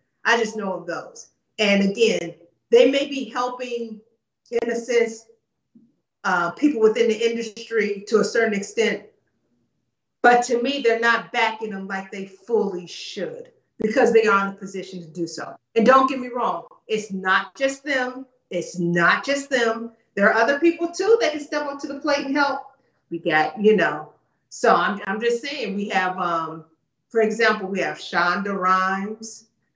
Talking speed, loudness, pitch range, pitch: 175 wpm, -21 LUFS, 195-245 Hz, 225 Hz